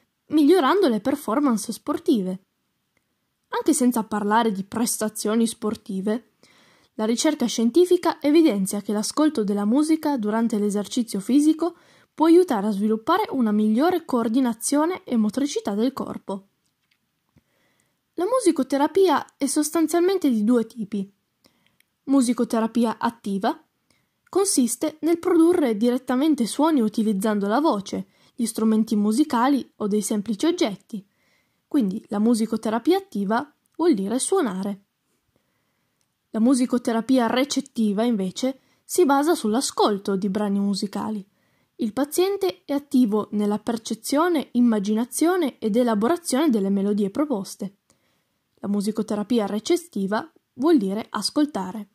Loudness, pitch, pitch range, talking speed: -22 LUFS, 235 Hz, 215-295 Hz, 105 wpm